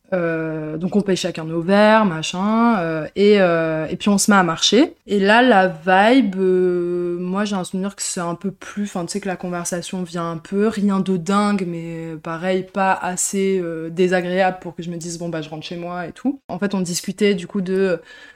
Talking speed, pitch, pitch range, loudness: 230 wpm, 185 Hz, 170-200 Hz, -19 LUFS